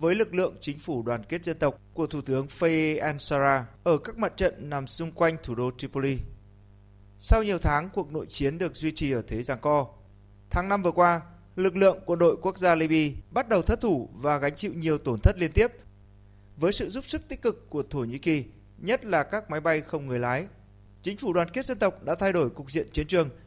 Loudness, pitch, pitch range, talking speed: -27 LUFS, 150 Hz, 120-175 Hz, 235 wpm